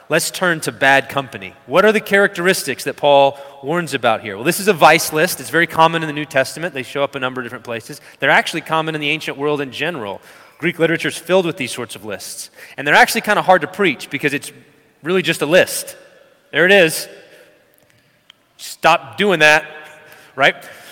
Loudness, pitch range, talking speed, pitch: -16 LUFS, 140-170 Hz, 210 wpm, 155 Hz